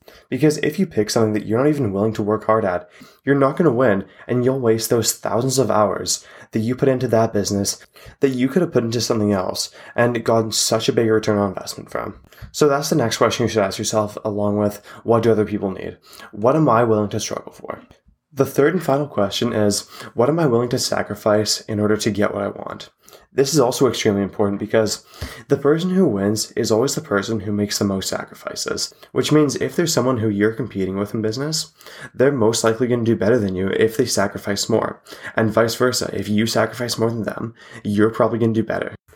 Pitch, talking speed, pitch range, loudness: 115 Hz, 230 wpm, 105-130 Hz, -19 LUFS